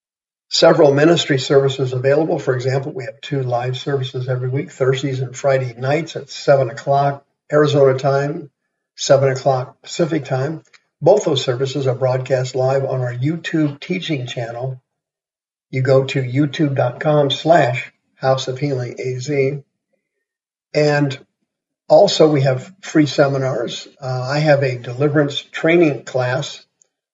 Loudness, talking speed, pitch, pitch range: -17 LUFS, 130 wpm, 140 Hz, 130-150 Hz